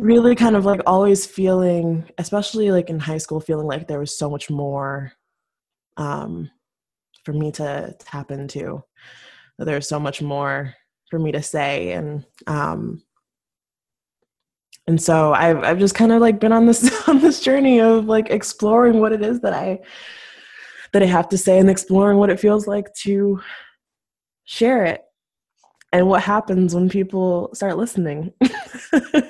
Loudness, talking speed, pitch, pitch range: -18 LUFS, 160 wpm, 185 Hz, 155-215 Hz